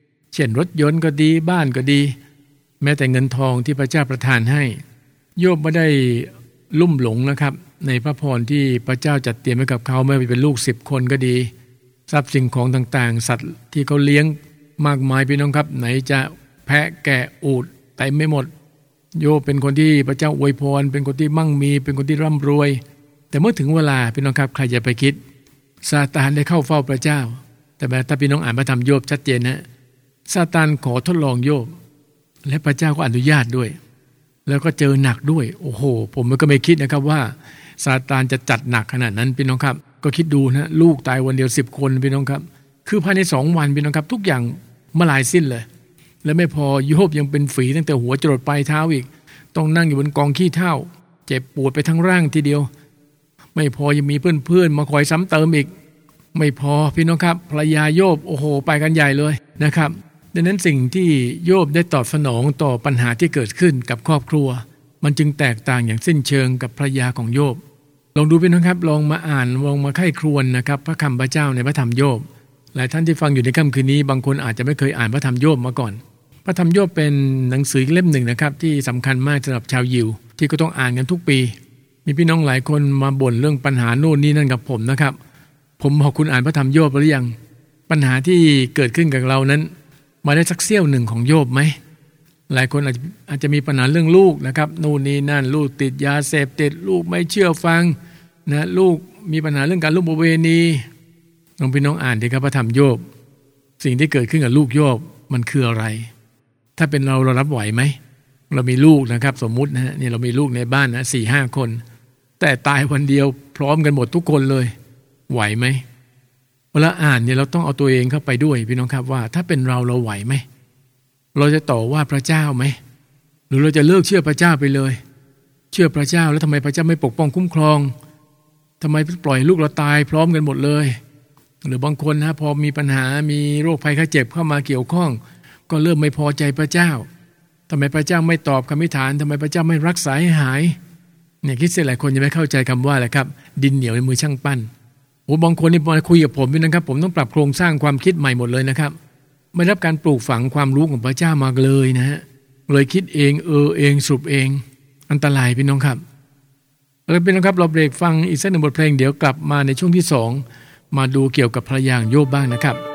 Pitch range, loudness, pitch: 135-155 Hz, -17 LUFS, 145 Hz